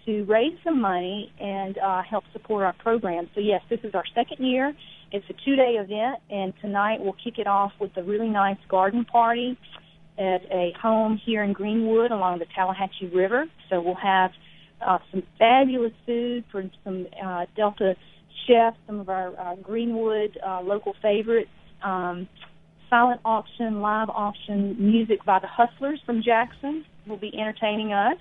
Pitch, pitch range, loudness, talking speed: 210 Hz, 190-230 Hz, -25 LUFS, 170 wpm